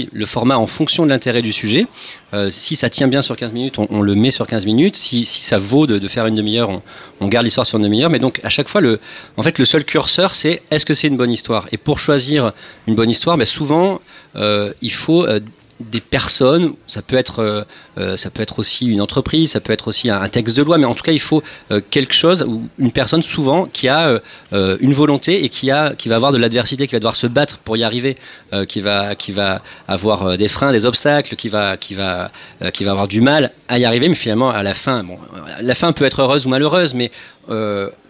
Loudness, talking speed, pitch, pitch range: -15 LUFS, 245 wpm, 120 Hz, 105-140 Hz